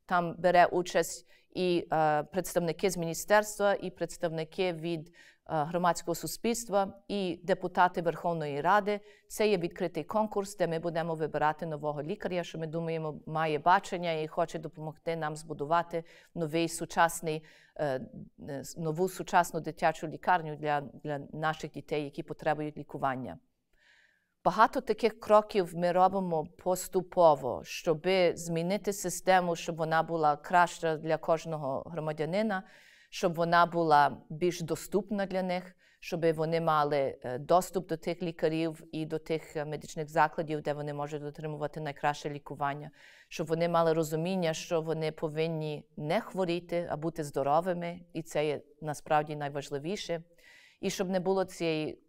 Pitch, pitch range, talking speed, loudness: 165 Hz, 155-180 Hz, 130 wpm, -31 LUFS